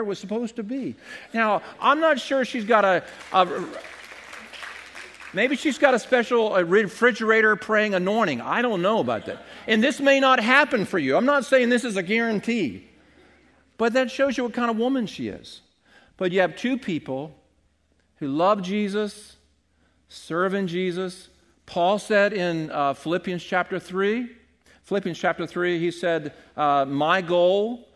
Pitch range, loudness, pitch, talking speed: 175-240 Hz, -23 LUFS, 205 Hz, 160 wpm